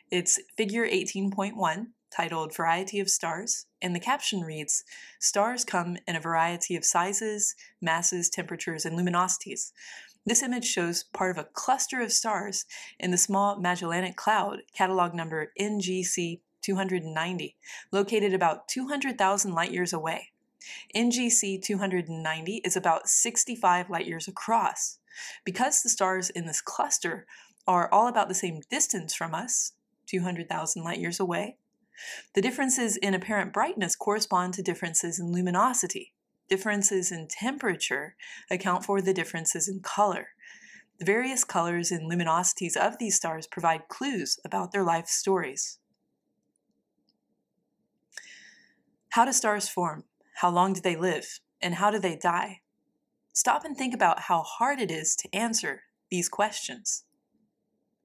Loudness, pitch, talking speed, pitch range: -27 LUFS, 190 Hz, 135 wpm, 175-210 Hz